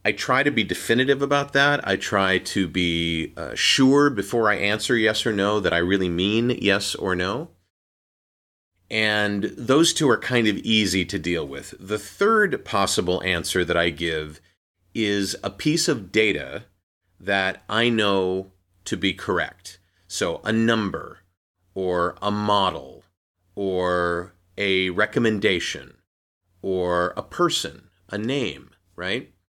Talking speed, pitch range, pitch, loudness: 140 wpm, 90-110 Hz, 95 Hz, -22 LUFS